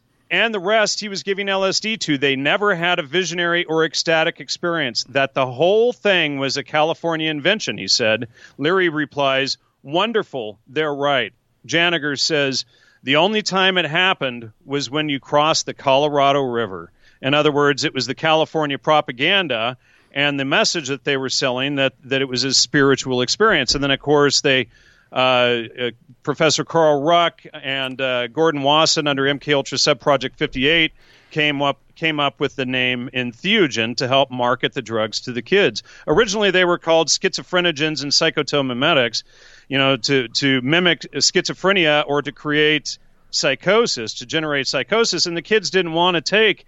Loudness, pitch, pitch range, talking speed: -18 LUFS, 145 Hz, 135-165 Hz, 165 wpm